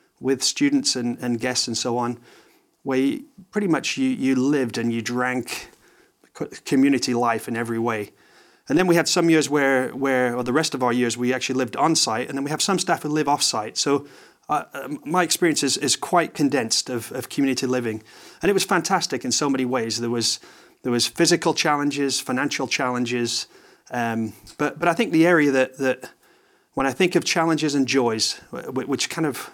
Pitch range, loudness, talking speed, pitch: 125-165 Hz, -22 LUFS, 195 wpm, 135 Hz